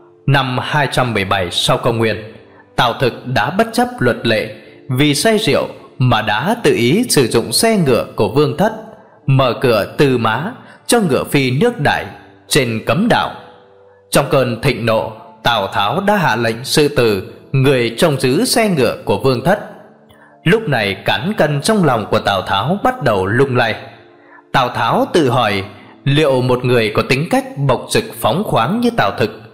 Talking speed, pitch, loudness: 175 wpm, 140 Hz, -15 LUFS